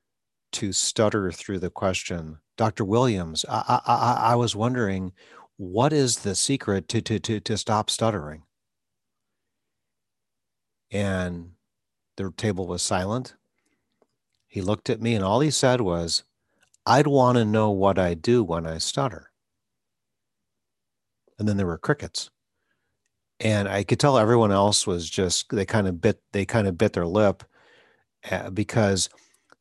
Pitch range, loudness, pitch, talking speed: 95-115 Hz, -24 LUFS, 100 Hz, 140 wpm